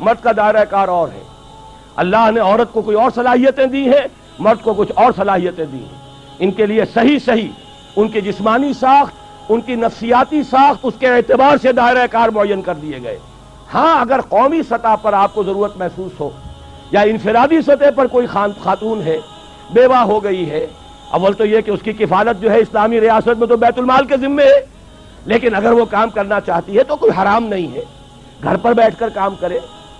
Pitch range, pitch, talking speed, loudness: 195-245 Hz, 220 Hz, 205 wpm, -14 LUFS